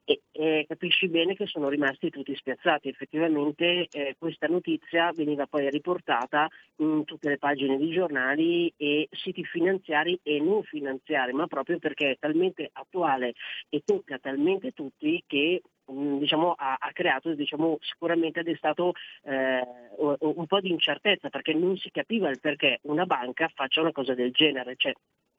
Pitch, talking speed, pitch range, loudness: 155 Hz, 160 wpm, 145-175 Hz, -27 LUFS